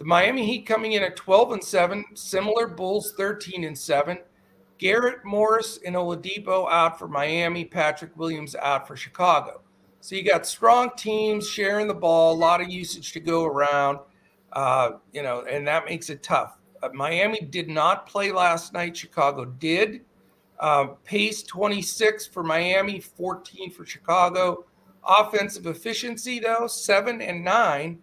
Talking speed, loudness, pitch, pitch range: 155 wpm, -23 LUFS, 180 Hz, 165-210 Hz